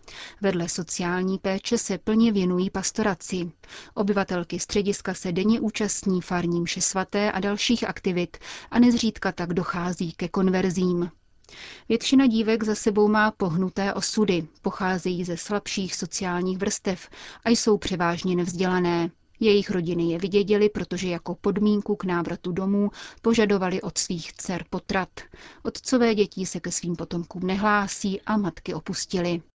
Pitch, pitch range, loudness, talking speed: 190 Hz, 180-210 Hz, -25 LUFS, 130 wpm